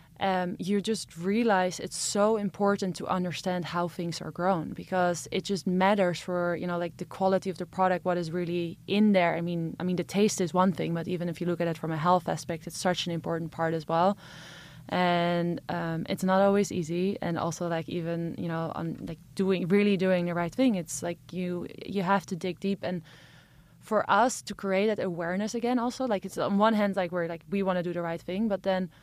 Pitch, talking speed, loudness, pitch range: 180 Hz, 230 wpm, -29 LUFS, 170-195 Hz